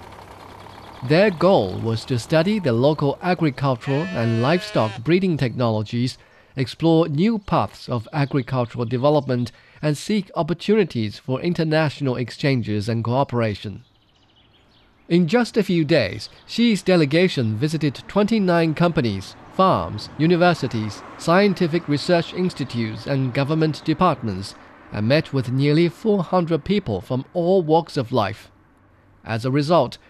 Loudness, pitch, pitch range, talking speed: -21 LUFS, 140 Hz, 115-170 Hz, 115 wpm